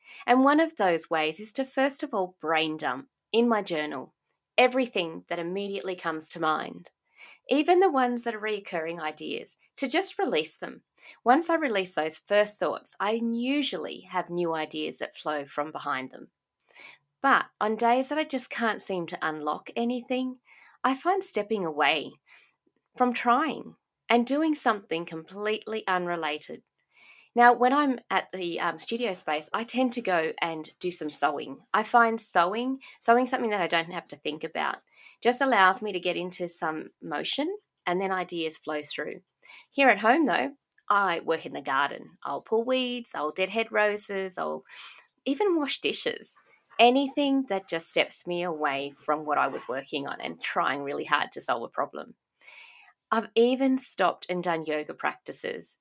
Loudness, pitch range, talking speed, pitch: -27 LUFS, 170-250 Hz, 170 wpm, 210 Hz